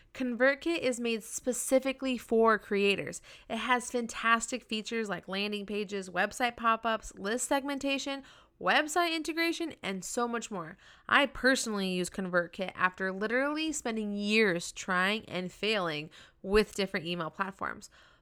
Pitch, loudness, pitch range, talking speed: 225 Hz, -31 LUFS, 195-255 Hz, 130 wpm